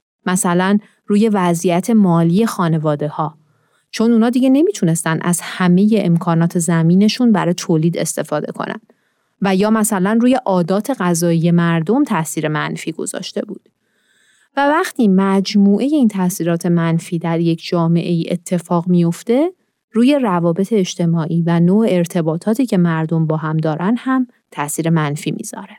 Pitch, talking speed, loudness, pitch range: 180 Hz, 130 wpm, -16 LUFS, 170-215 Hz